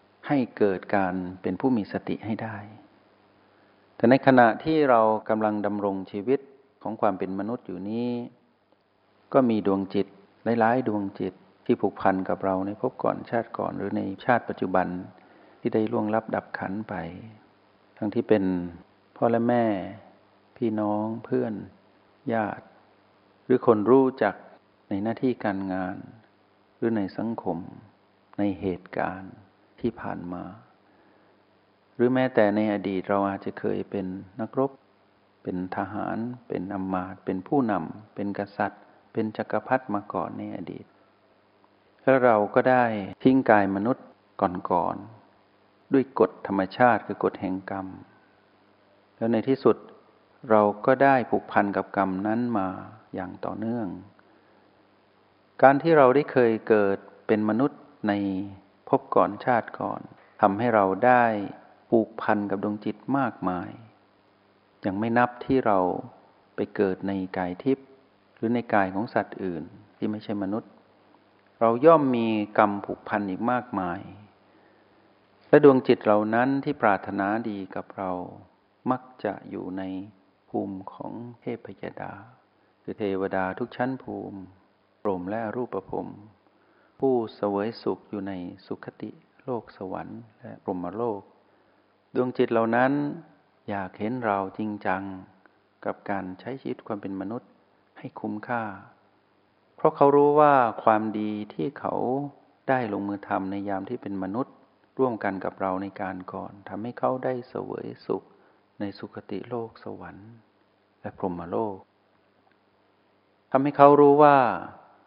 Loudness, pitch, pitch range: -26 LUFS, 105 Hz, 95-115 Hz